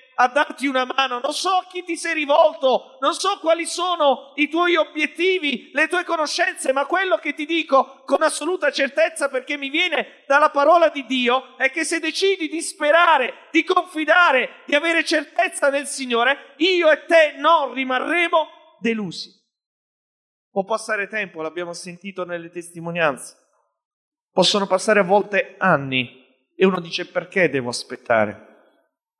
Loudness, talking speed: -19 LUFS, 150 wpm